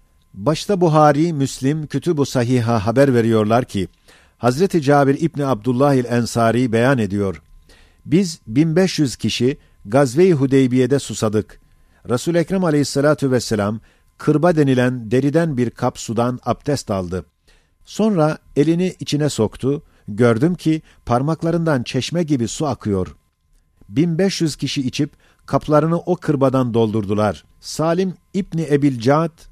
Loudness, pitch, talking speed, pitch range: -18 LUFS, 135 Hz, 110 wpm, 110-155 Hz